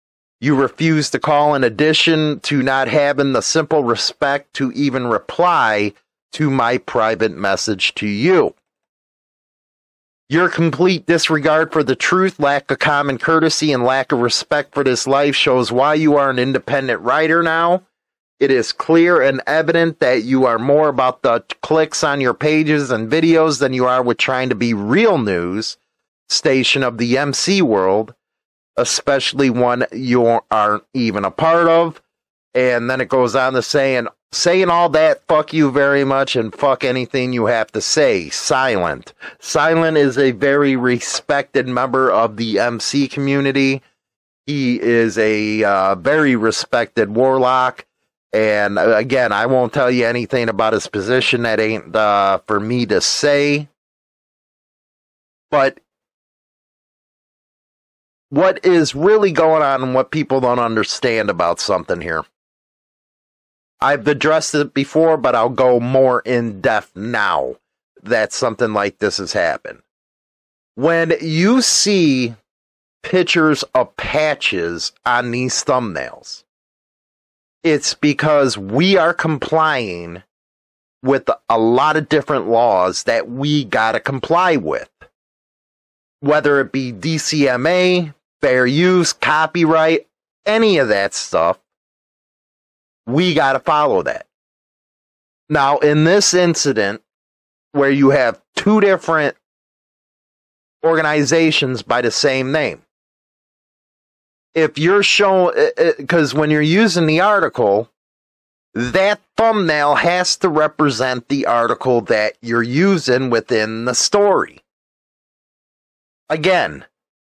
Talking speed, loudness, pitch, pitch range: 130 wpm, -15 LUFS, 140 Hz, 120-160 Hz